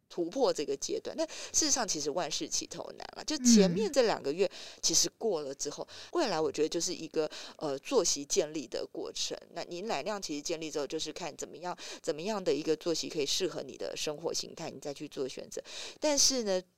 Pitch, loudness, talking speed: 195 Hz, -32 LUFS, 325 characters per minute